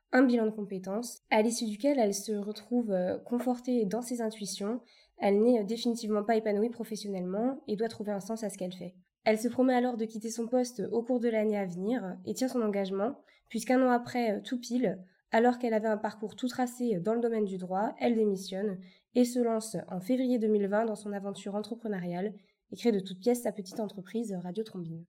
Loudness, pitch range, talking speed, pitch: -31 LUFS, 200-240 Hz, 205 wpm, 220 Hz